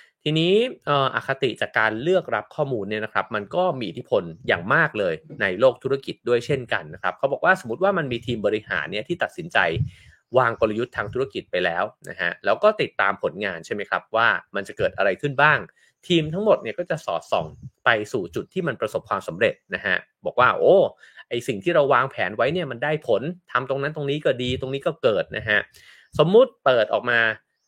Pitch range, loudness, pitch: 125-195 Hz, -23 LUFS, 150 Hz